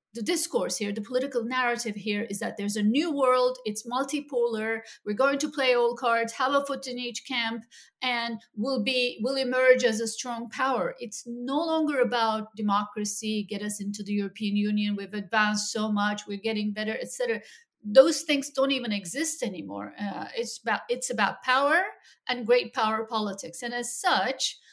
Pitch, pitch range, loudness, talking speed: 235 Hz, 215-260 Hz, -27 LUFS, 180 wpm